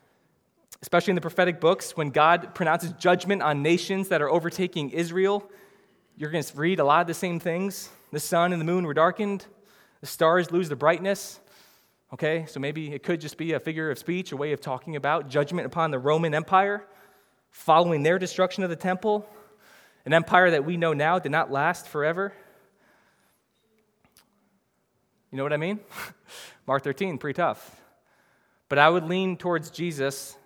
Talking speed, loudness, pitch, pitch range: 175 wpm, -25 LUFS, 170 Hz, 155-190 Hz